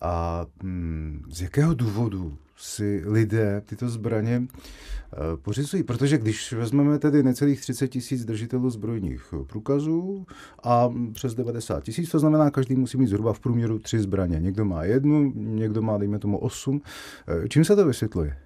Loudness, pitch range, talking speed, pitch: -25 LUFS, 100-135 Hz, 145 wpm, 115 Hz